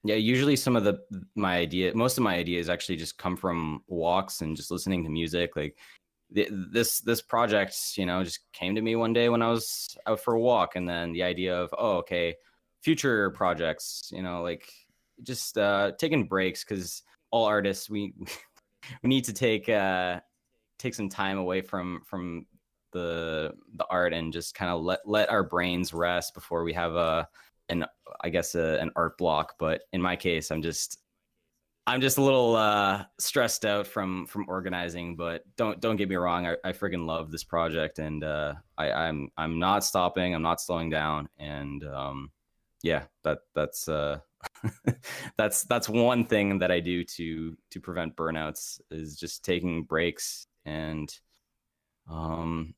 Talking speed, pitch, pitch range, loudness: 180 wpm, 90 Hz, 80-105 Hz, -29 LUFS